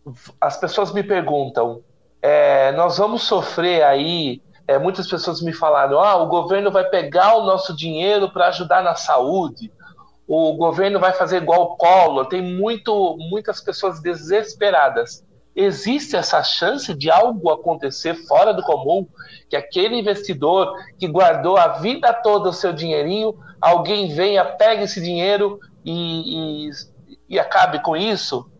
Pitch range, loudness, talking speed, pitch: 165-200 Hz, -18 LUFS, 145 wpm, 180 Hz